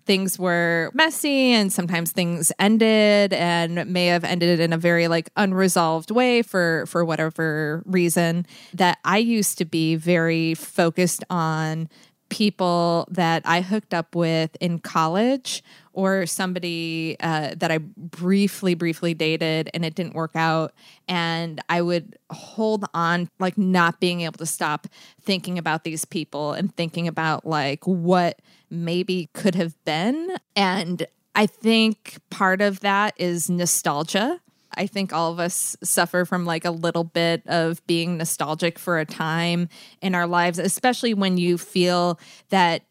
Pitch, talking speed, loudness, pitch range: 175 Hz, 150 wpm, -22 LUFS, 165-190 Hz